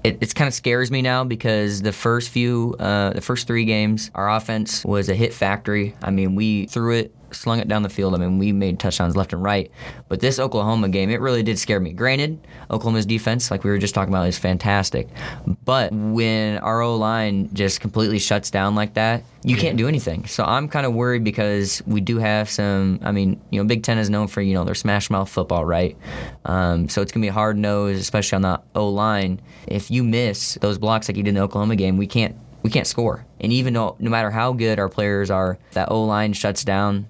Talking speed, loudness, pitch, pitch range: 235 wpm, -21 LUFS, 105 Hz, 100-115 Hz